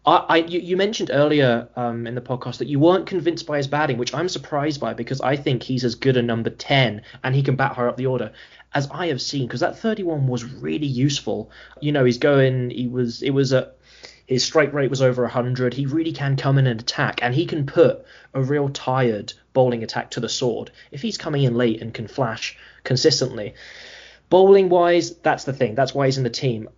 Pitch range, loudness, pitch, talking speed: 125-150 Hz, -21 LUFS, 135 Hz, 230 wpm